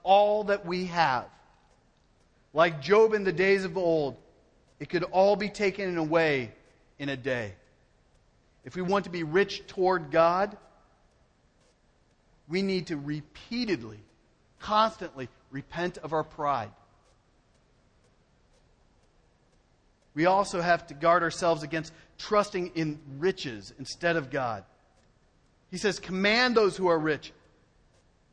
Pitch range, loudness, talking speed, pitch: 145-190 Hz, -27 LUFS, 120 wpm, 170 Hz